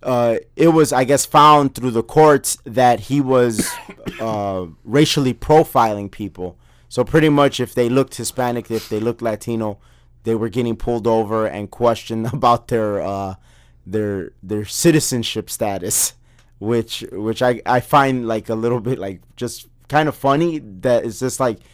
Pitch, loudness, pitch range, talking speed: 120 Hz, -18 LUFS, 110-130 Hz, 165 wpm